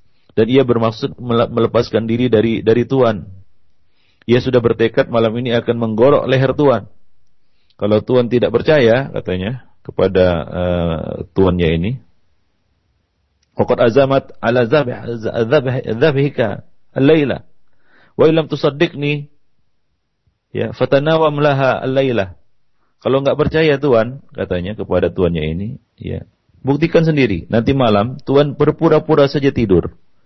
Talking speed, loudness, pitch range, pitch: 100 wpm, -15 LUFS, 100-140 Hz, 120 Hz